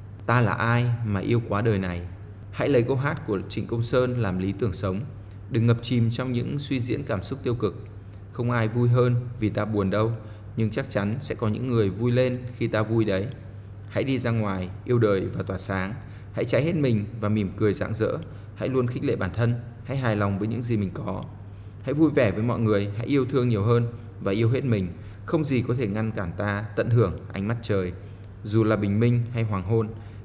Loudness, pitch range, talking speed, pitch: -25 LUFS, 100-120 Hz, 235 wpm, 110 Hz